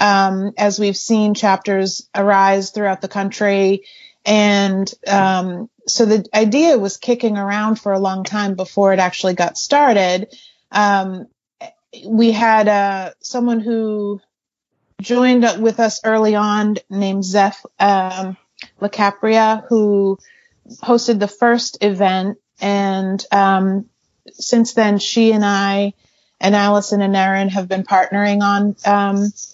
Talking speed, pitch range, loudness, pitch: 125 wpm, 195-220 Hz, -16 LUFS, 205 Hz